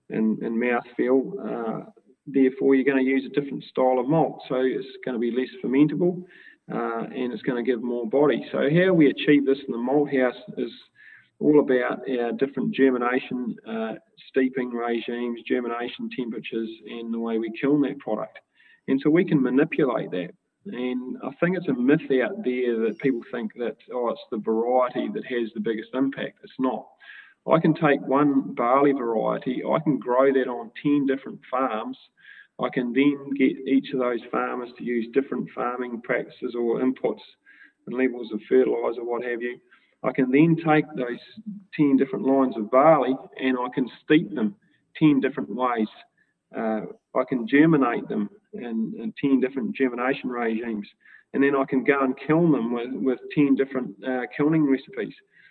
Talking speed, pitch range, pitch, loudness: 180 wpm, 120-145 Hz, 130 Hz, -24 LUFS